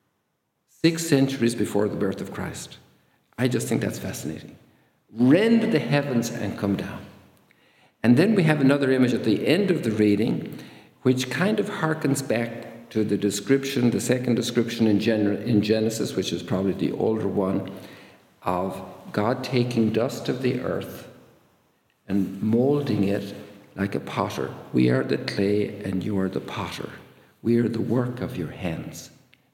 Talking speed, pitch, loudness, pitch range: 160 wpm, 115 Hz, -24 LUFS, 100-130 Hz